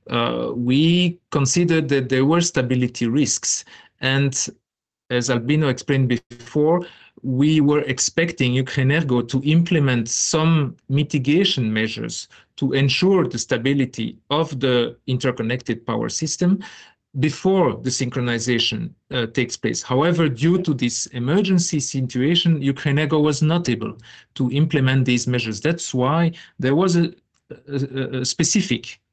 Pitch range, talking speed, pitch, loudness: 125-160 Hz, 120 wpm, 140 Hz, -20 LUFS